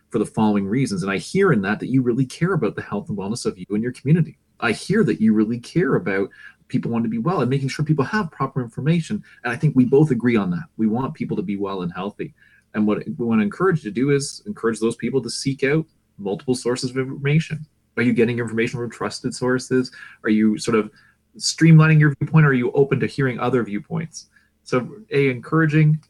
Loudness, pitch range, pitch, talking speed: -21 LUFS, 115-155 Hz, 130 Hz, 235 wpm